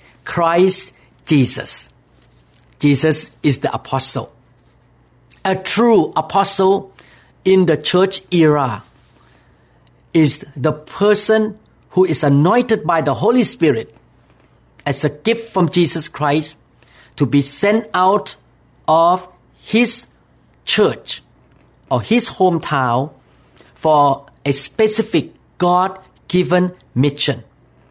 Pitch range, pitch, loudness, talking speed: 135-190 Hz, 155 Hz, -16 LUFS, 95 wpm